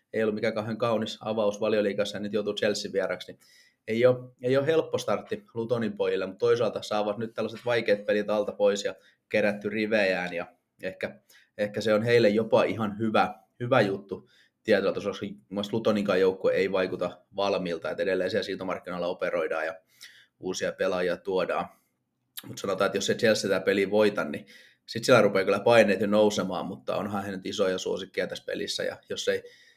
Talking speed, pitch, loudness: 180 wpm, 120 Hz, -27 LUFS